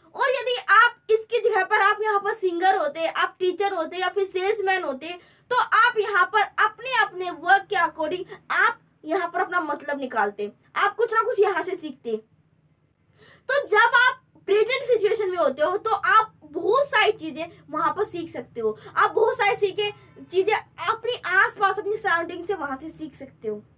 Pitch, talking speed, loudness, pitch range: 390 Hz, 185 wpm, -22 LUFS, 330-430 Hz